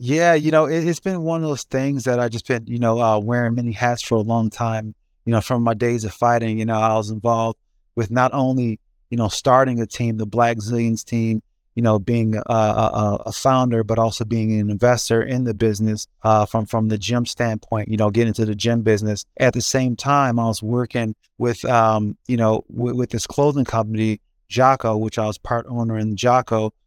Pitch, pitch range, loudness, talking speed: 115 Hz, 110-120 Hz, -20 LUFS, 225 wpm